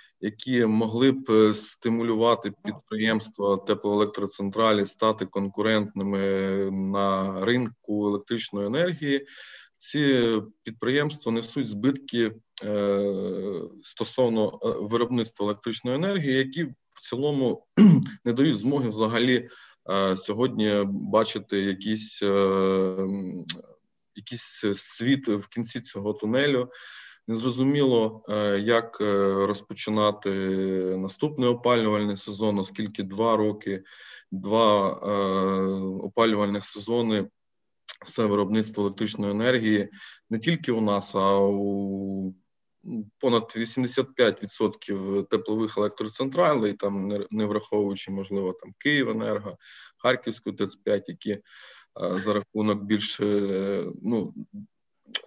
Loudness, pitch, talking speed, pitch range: -26 LUFS, 105 Hz, 85 wpm, 100-120 Hz